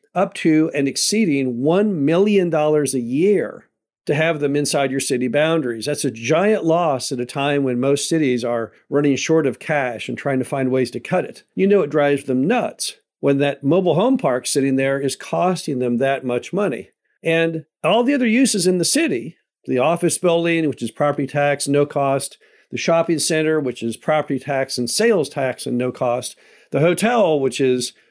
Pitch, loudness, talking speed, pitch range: 145 Hz, -19 LUFS, 195 wpm, 135-165 Hz